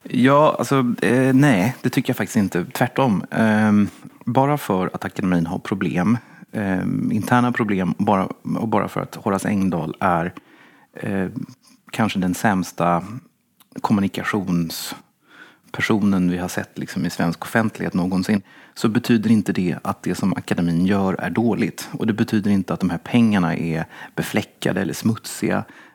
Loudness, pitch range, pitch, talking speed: -21 LUFS, 90-120 Hz, 105 Hz, 150 wpm